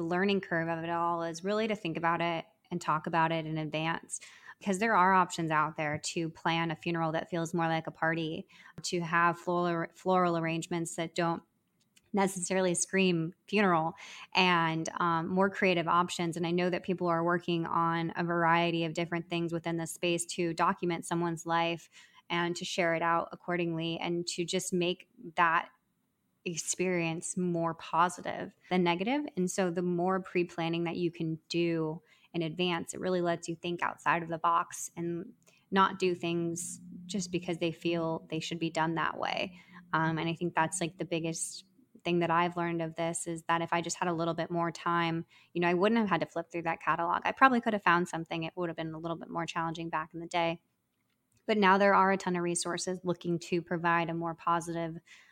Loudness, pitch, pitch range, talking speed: -31 LUFS, 170 Hz, 165-180 Hz, 205 wpm